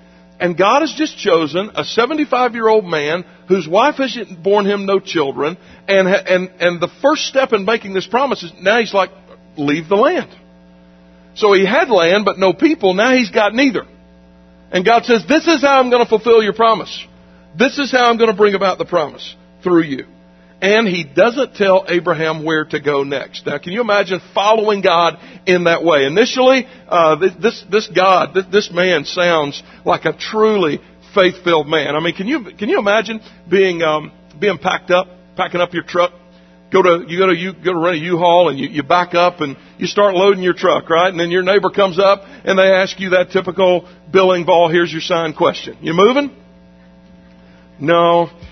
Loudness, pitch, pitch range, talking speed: -14 LUFS, 185 Hz, 165-205 Hz, 200 wpm